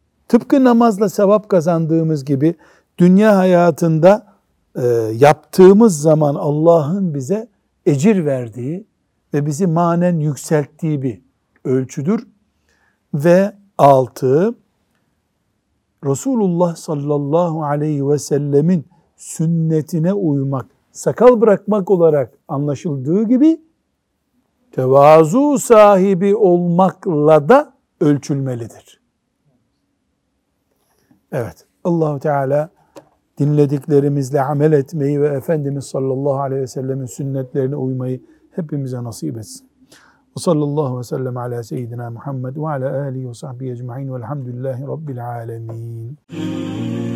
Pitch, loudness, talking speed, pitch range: 150 Hz, -16 LUFS, 80 wpm, 135-180 Hz